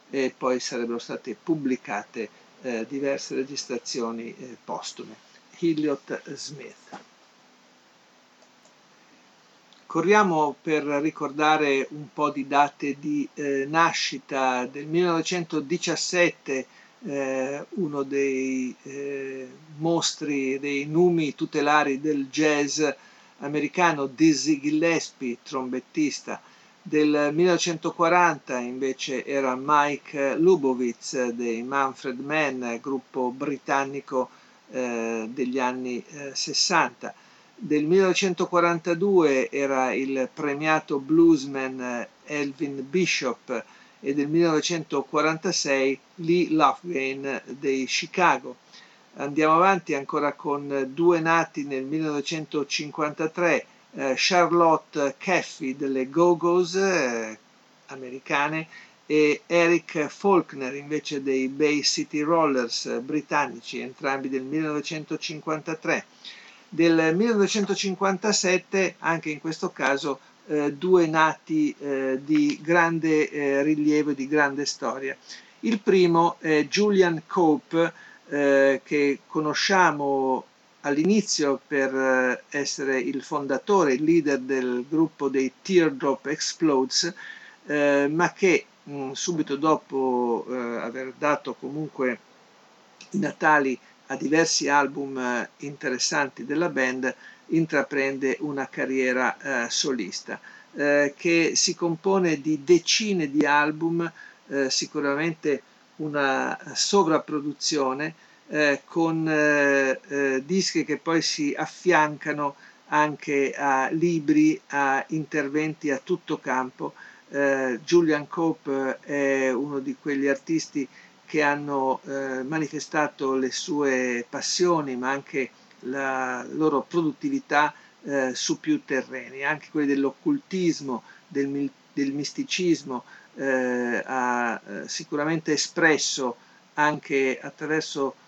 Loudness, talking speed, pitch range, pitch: -24 LUFS, 95 wpm, 135-165 Hz, 145 Hz